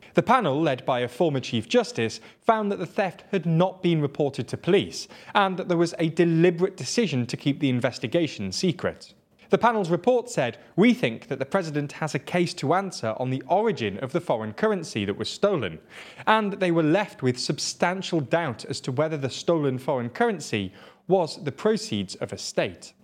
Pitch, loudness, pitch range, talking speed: 165 Hz, -25 LUFS, 130-190 Hz, 195 wpm